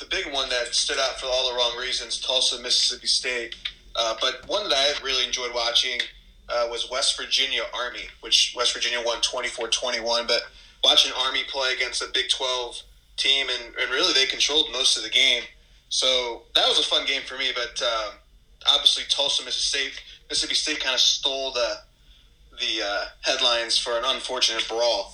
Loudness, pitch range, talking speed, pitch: -22 LUFS, 120-130 Hz, 185 wpm, 125 Hz